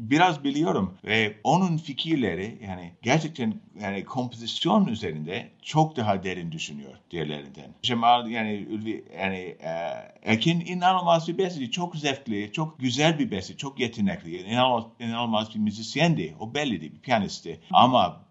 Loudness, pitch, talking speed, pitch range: -26 LUFS, 125 Hz, 140 wpm, 105-165 Hz